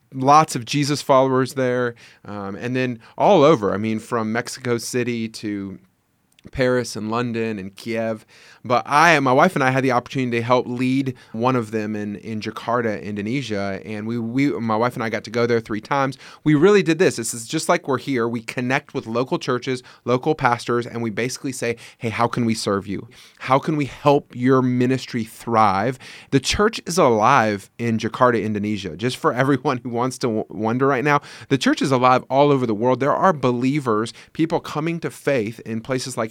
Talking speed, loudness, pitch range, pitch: 200 wpm, -20 LUFS, 115-135 Hz, 125 Hz